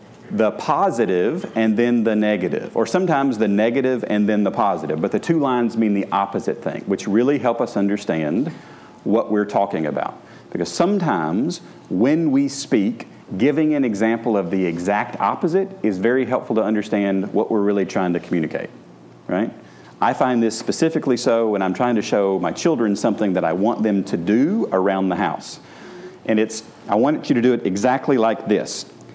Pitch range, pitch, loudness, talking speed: 100-125 Hz, 110 Hz, -20 LUFS, 180 wpm